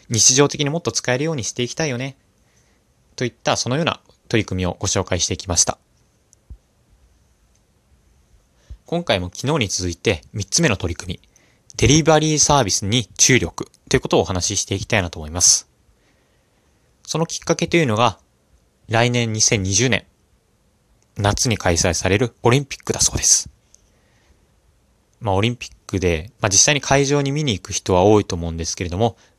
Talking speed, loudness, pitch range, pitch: 330 characters per minute, -18 LUFS, 90-125 Hz, 105 Hz